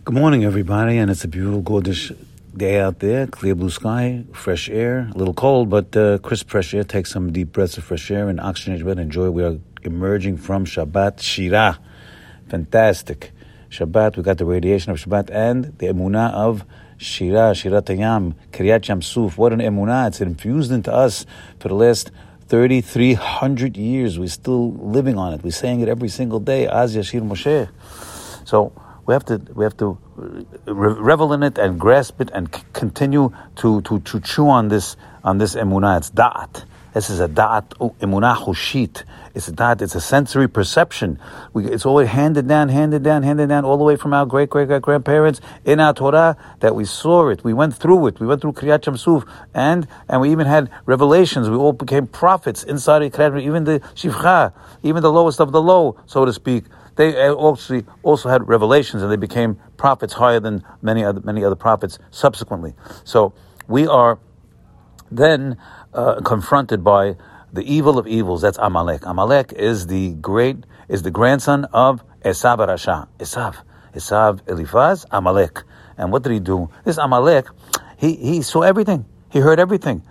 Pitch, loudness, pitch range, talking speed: 115 Hz, -17 LUFS, 100-140 Hz, 180 wpm